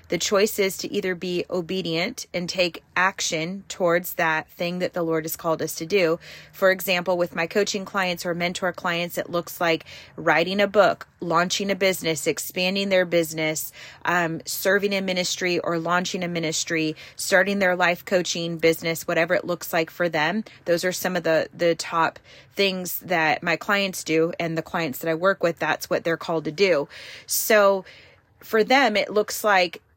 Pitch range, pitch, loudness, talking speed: 165-190 Hz, 175 Hz, -23 LUFS, 185 wpm